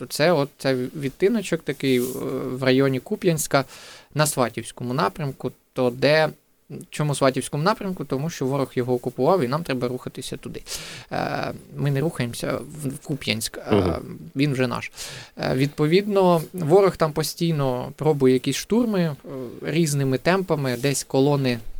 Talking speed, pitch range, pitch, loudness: 125 wpm, 130-160 Hz, 140 Hz, -23 LUFS